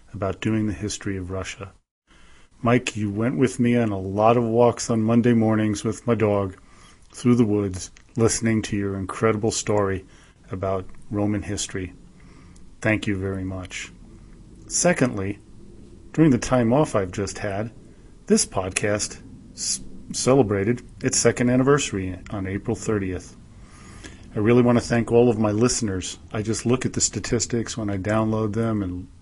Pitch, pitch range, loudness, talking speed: 110 Hz, 95-120 Hz, -23 LUFS, 155 wpm